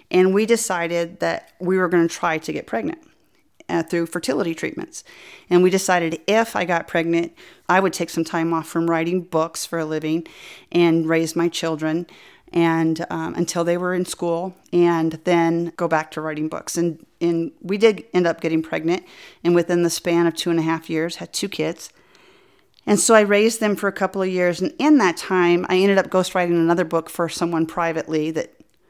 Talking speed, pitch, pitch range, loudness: 205 wpm, 170 Hz, 165-180 Hz, -20 LUFS